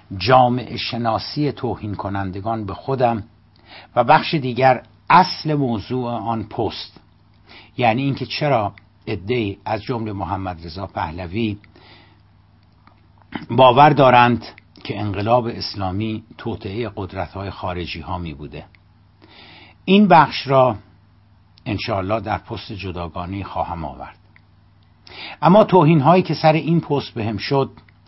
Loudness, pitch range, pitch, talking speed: -19 LUFS, 100-125 Hz, 110 Hz, 110 wpm